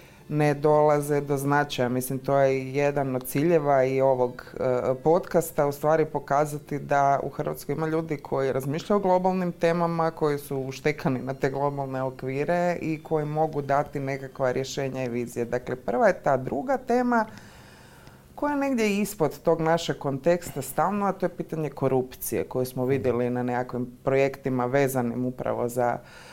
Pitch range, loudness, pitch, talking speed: 130-160 Hz, -26 LUFS, 145 Hz, 160 wpm